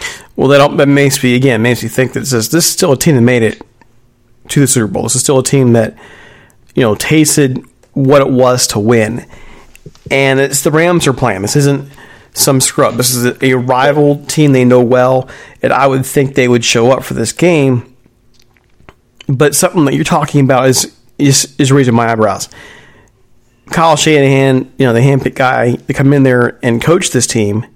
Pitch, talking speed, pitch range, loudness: 130 Hz, 200 wpm, 120-140 Hz, -10 LUFS